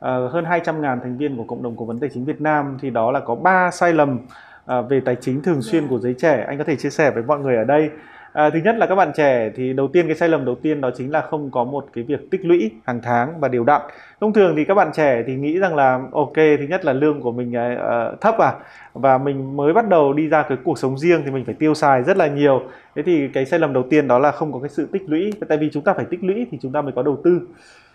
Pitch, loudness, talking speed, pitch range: 145 Hz, -19 LUFS, 295 wpm, 130-160 Hz